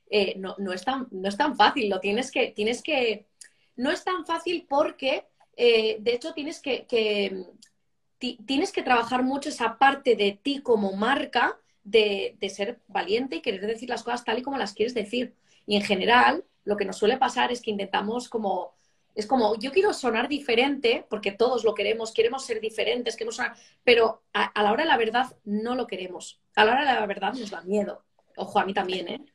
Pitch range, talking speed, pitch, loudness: 205-275 Hz, 210 wpm, 235 Hz, -25 LUFS